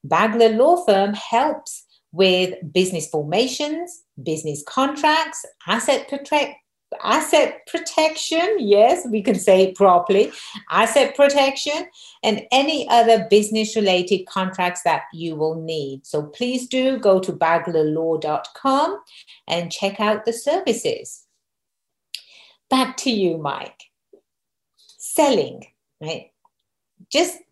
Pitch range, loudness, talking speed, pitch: 180-285 Hz, -19 LUFS, 105 wpm, 220 Hz